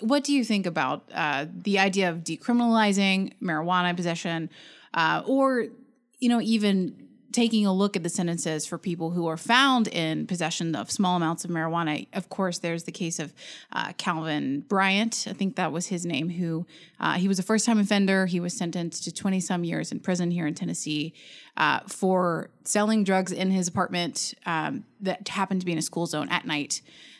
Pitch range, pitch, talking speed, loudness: 170-205 Hz, 185 Hz, 190 wpm, -26 LUFS